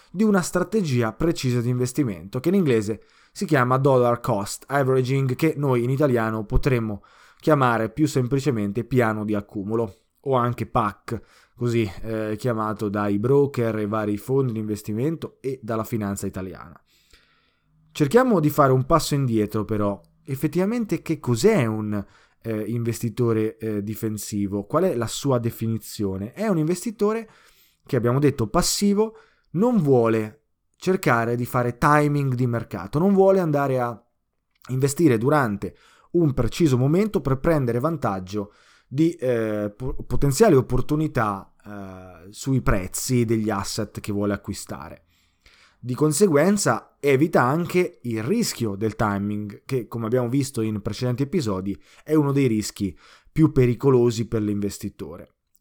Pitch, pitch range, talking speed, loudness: 120 Hz, 110-150 Hz, 135 wpm, -23 LUFS